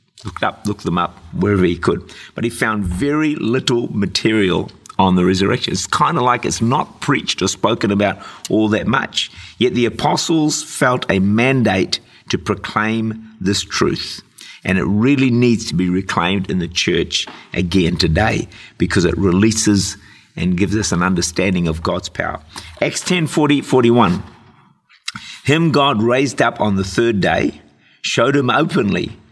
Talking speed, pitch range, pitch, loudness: 160 wpm, 95-125 Hz, 110 Hz, -17 LUFS